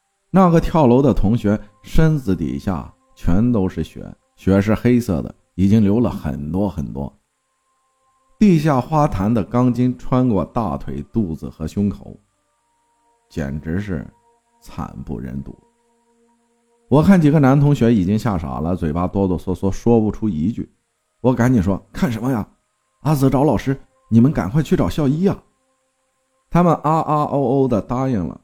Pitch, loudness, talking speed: 125 Hz, -18 LUFS, 225 characters per minute